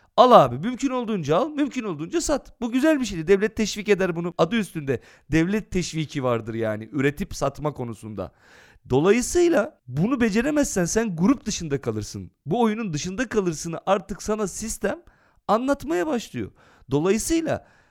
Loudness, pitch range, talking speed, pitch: -23 LUFS, 150-240 Hz, 140 wpm, 200 Hz